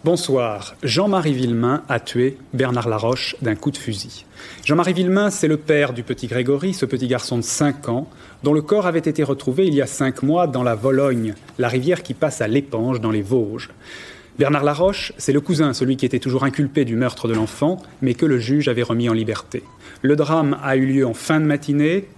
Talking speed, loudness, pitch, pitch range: 215 wpm, -20 LUFS, 135 Hz, 120-150 Hz